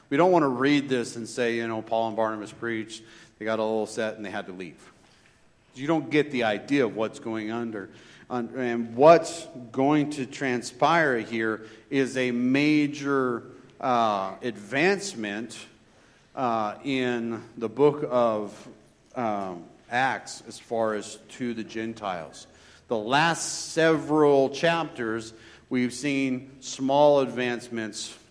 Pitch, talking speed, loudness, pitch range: 120 Hz, 140 wpm, -26 LUFS, 110-140 Hz